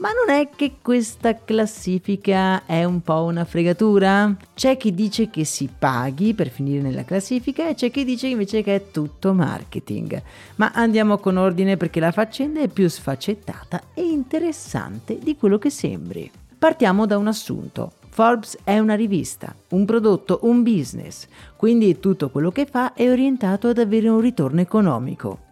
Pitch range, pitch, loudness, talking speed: 185-240 Hz, 210 Hz, -20 LUFS, 165 wpm